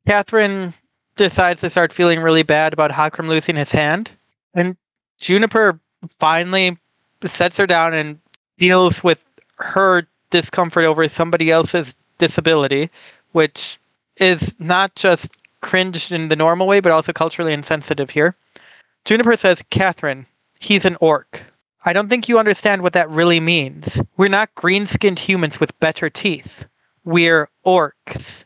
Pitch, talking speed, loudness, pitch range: 170 Hz, 135 wpm, -16 LUFS, 155-185 Hz